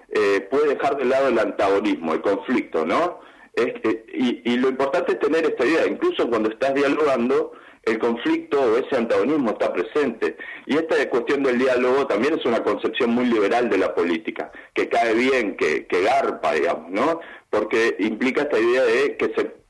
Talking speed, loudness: 185 wpm, -21 LUFS